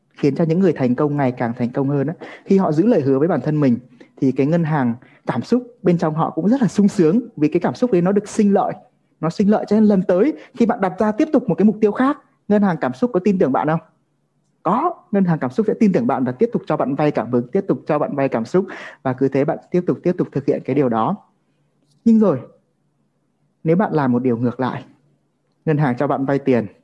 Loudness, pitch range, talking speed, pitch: -18 LUFS, 140-210 Hz, 275 wpm, 165 Hz